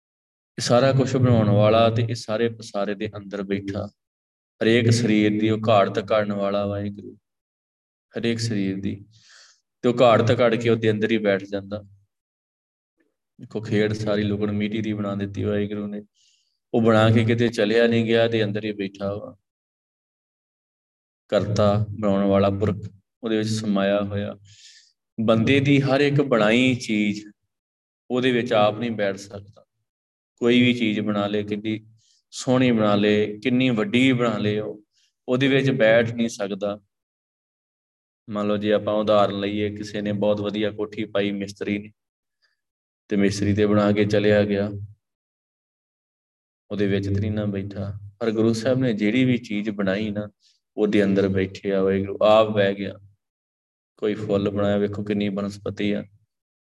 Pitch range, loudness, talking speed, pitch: 100-110 Hz, -22 LUFS, 150 wpm, 105 Hz